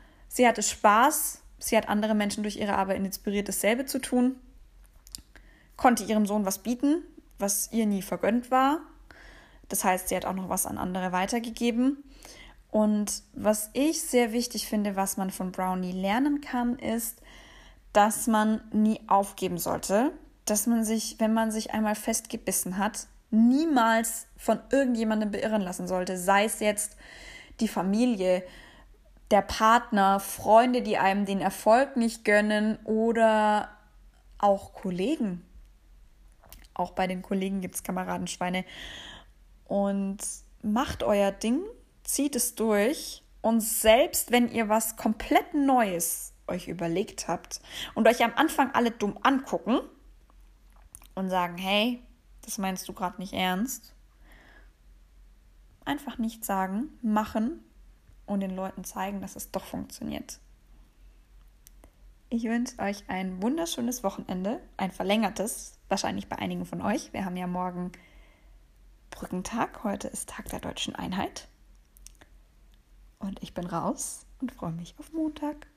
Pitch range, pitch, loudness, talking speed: 190-240 Hz, 215 Hz, -27 LUFS, 135 wpm